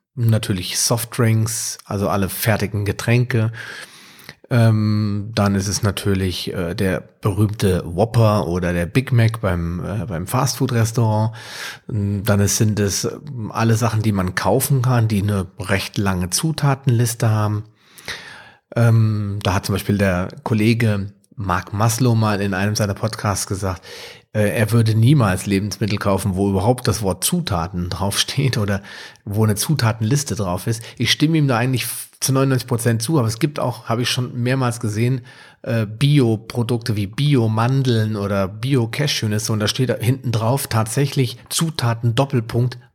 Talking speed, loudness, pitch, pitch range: 135 wpm, -19 LUFS, 110 Hz, 100-120 Hz